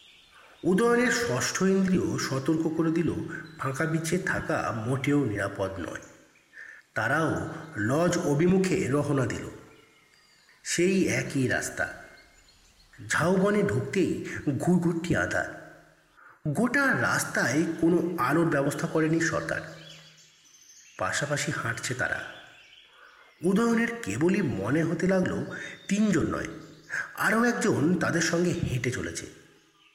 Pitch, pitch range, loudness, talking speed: 165 Hz, 145-180 Hz, -27 LUFS, 95 wpm